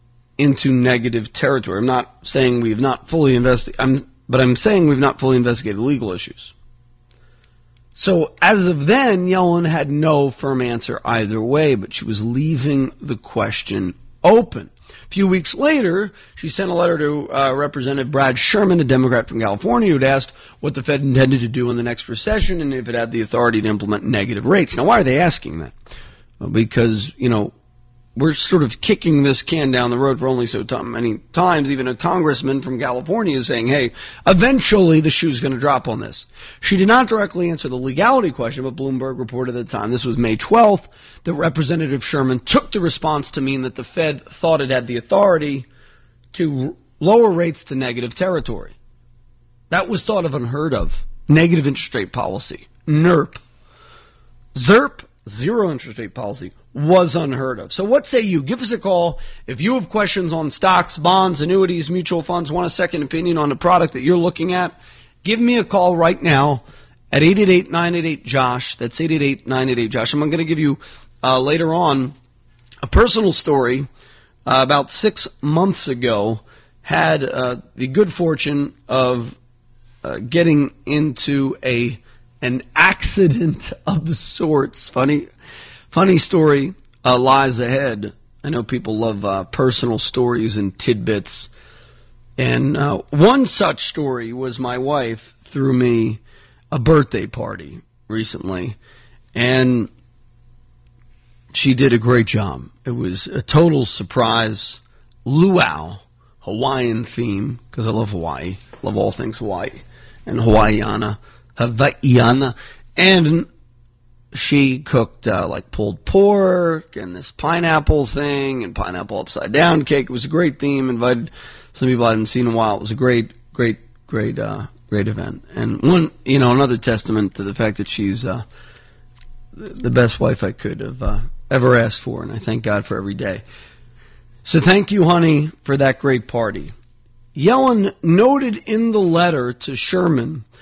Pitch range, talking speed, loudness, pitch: 120-160 Hz, 165 wpm, -17 LUFS, 130 Hz